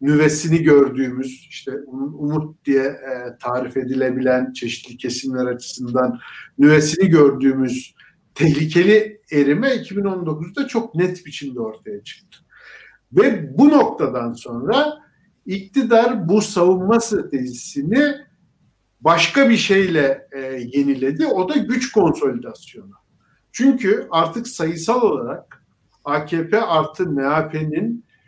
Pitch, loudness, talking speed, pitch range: 155 Hz, -18 LUFS, 90 wpm, 135-200 Hz